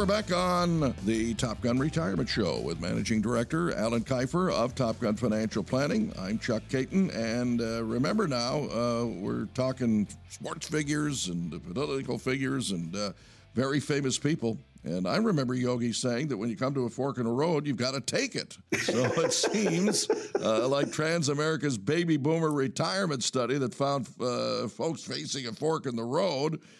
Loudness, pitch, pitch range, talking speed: -29 LUFS, 130 Hz, 115-150 Hz, 175 wpm